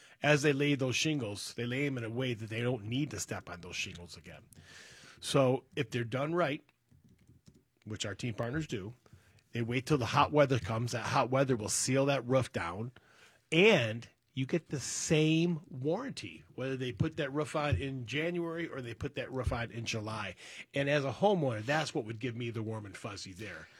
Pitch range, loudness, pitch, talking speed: 115-145 Hz, -33 LUFS, 130 Hz, 205 wpm